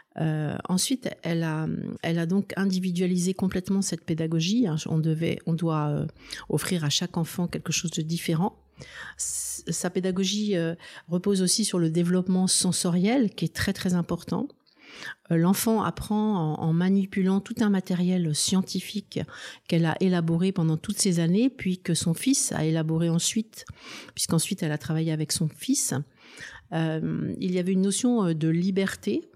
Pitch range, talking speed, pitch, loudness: 165-195 Hz, 160 wpm, 180 Hz, -26 LUFS